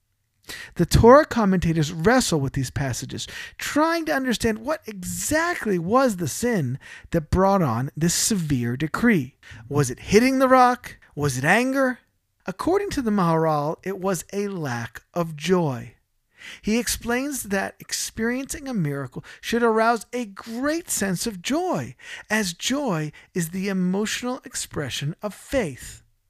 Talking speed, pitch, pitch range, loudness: 135 wpm, 195 Hz, 150-245 Hz, -23 LUFS